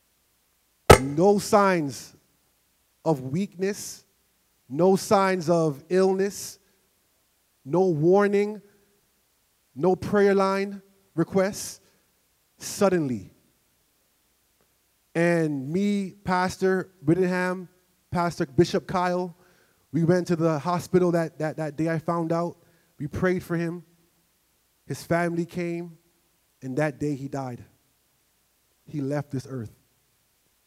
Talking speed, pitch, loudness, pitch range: 100 wpm, 170 Hz, -25 LUFS, 155-185 Hz